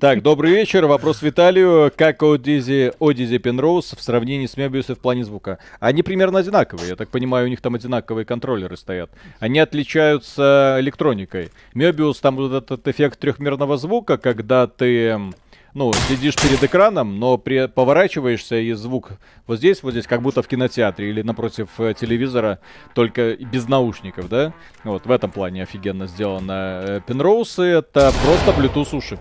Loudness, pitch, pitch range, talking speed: -18 LUFS, 125 Hz, 115-145 Hz, 150 wpm